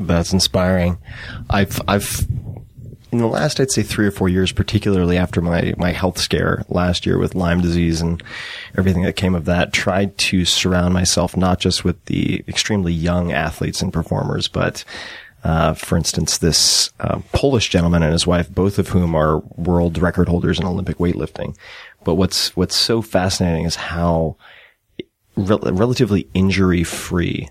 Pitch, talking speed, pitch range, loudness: 90 Hz, 165 wpm, 85-100 Hz, -18 LUFS